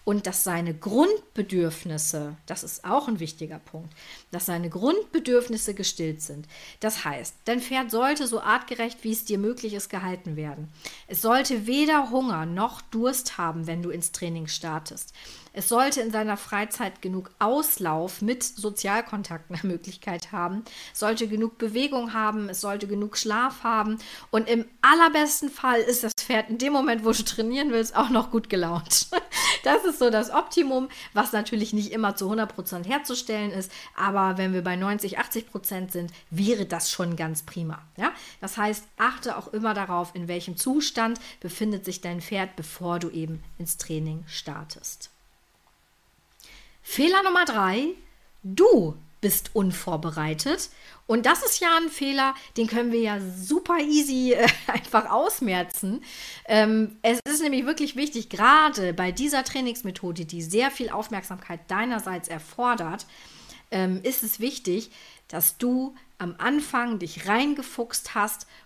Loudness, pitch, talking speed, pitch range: -25 LUFS, 215 Hz, 150 wpm, 180-245 Hz